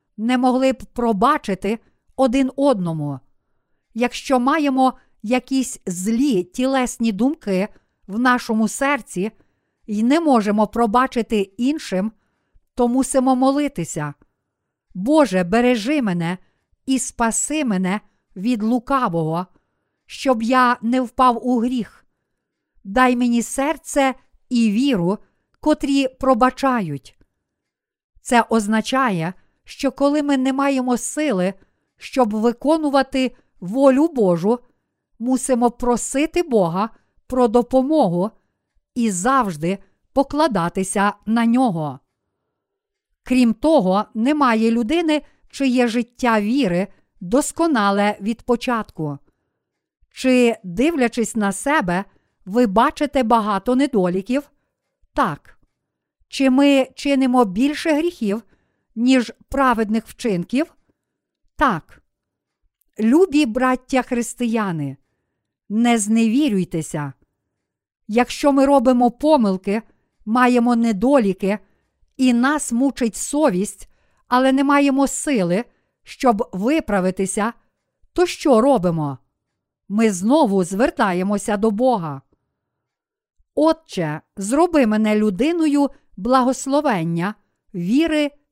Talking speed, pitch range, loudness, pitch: 85 wpm, 205-270 Hz, -19 LUFS, 245 Hz